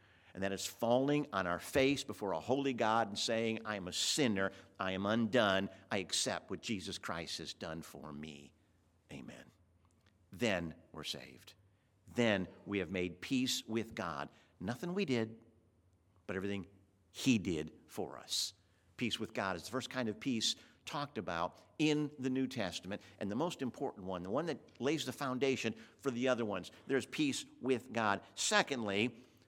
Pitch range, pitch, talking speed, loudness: 95-125 Hz, 105 Hz, 170 wpm, -37 LUFS